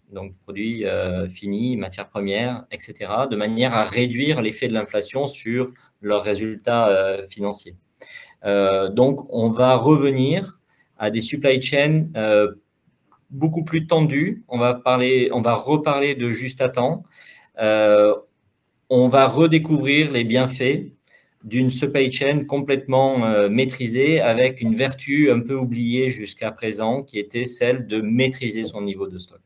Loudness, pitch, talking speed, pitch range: -20 LUFS, 125 Hz, 145 wpm, 105-135 Hz